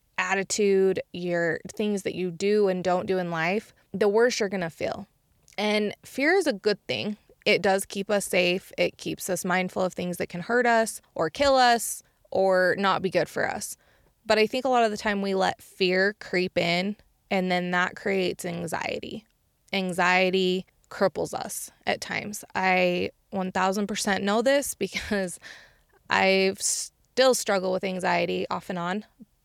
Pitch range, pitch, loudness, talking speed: 180-210 Hz, 190 Hz, -25 LUFS, 170 wpm